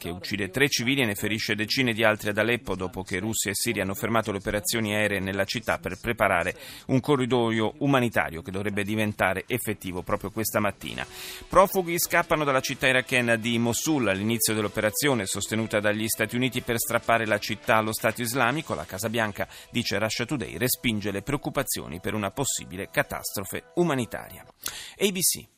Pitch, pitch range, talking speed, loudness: 110 Hz, 105-125 Hz, 165 wpm, -26 LUFS